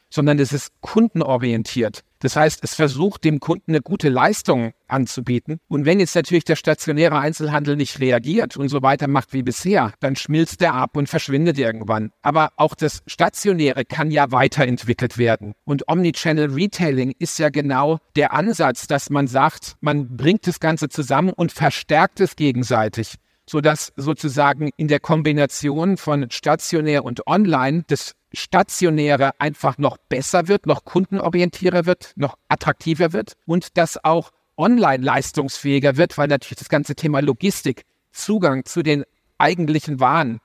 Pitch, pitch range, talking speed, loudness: 150 Hz, 135-165 Hz, 150 wpm, -19 LUFS